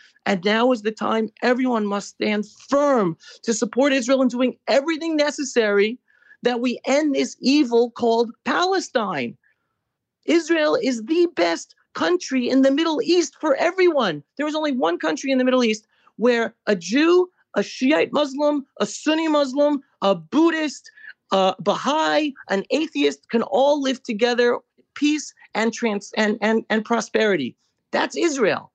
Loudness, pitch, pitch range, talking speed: -21 LUFS, 255 Hz, 215-295 Hz, 150 wpm